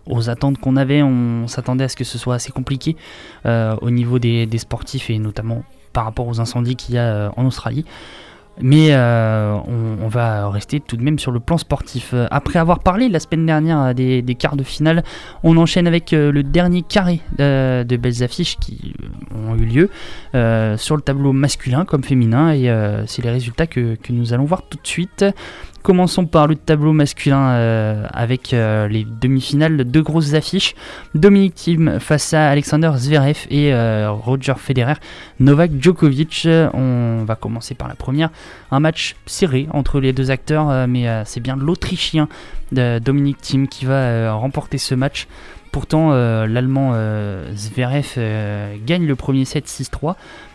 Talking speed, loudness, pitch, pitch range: 180 wpm, -17 LUFS, 135 Hz, 120-155 Hz